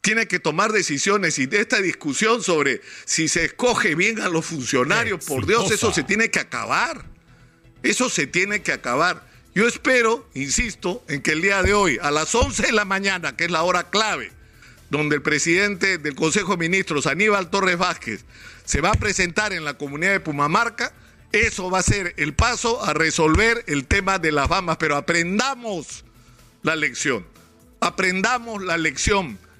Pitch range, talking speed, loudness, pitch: 160-210 Hz, 175 wpm, -20 LUFS, 185 Hz